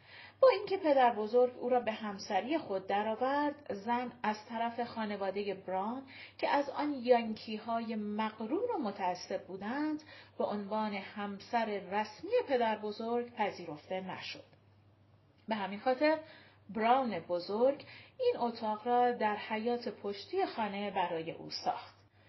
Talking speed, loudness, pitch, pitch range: 125 wpm, -34 LUFS, 220 Hz, 200-250 Hz